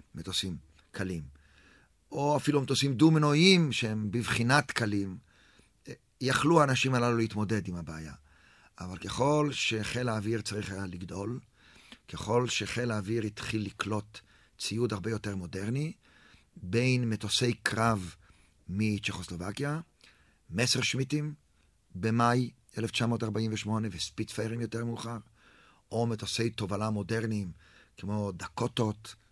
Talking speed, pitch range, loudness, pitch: 100 wpm, 100-120 Hz, -30 LUFS, 110 Hz